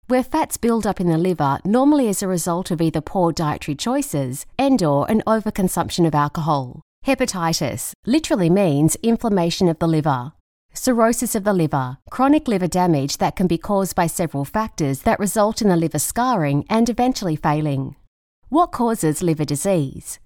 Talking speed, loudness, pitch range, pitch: 165 wpm, -20 LUFS, 155-225 Hz, 180 Hz